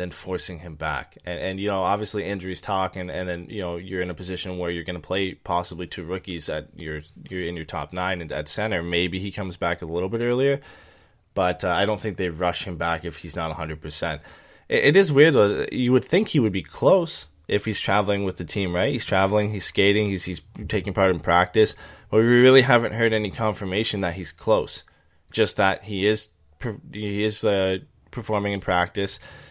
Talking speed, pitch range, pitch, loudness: 220 wpm, 90-105 Hz, 95 Hz, -23 LUFS